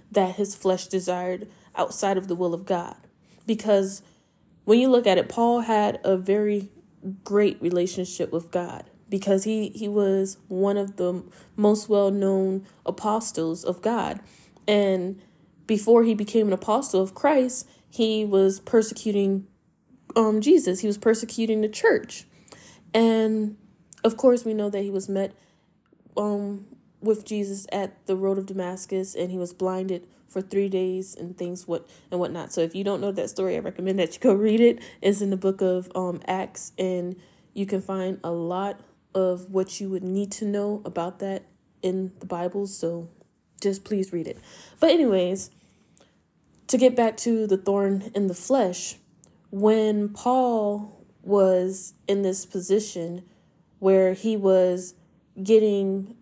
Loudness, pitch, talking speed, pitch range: -24 LUFS, 195 Hz, 160 wpm, 185-210 Hz